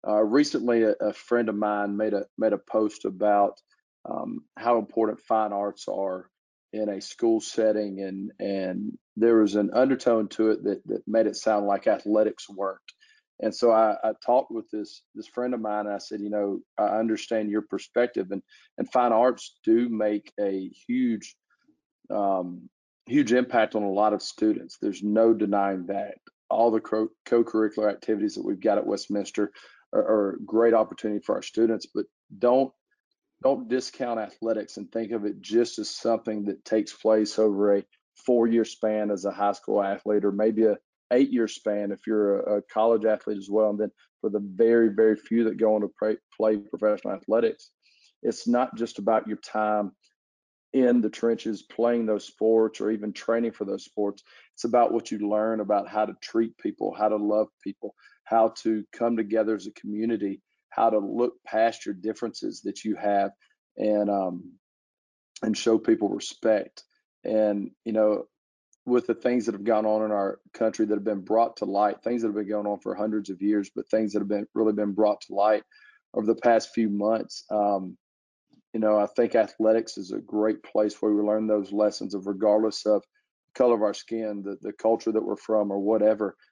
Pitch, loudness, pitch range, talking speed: 110 Hz, -26 LUFS, 105-115 Hz, 190 wpm